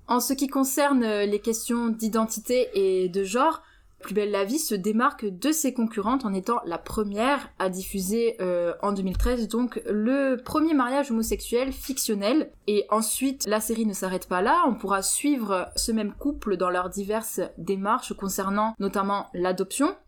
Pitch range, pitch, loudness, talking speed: 195-260 Hz, 220 Hz, -26 LUFS, 165 wpm